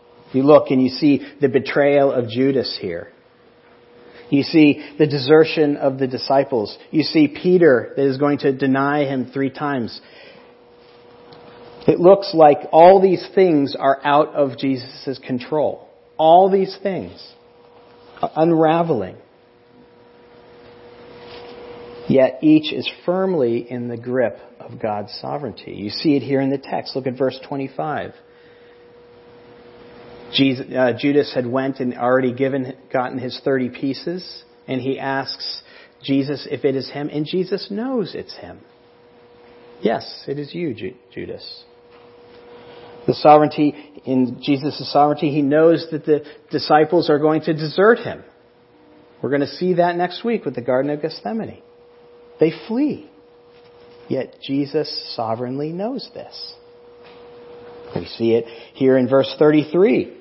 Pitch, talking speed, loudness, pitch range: 140 Hz, 135 wpm, -18 LUFS, 125-160 Hz